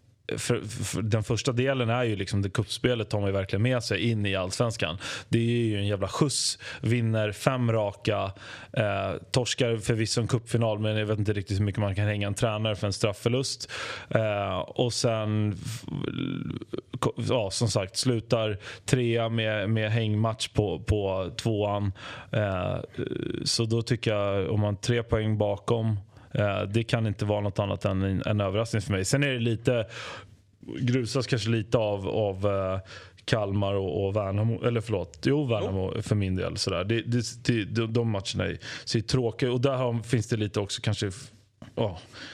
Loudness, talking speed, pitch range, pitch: -28 LUFS, 165 wpm, 100-120 Hz, 110 Hz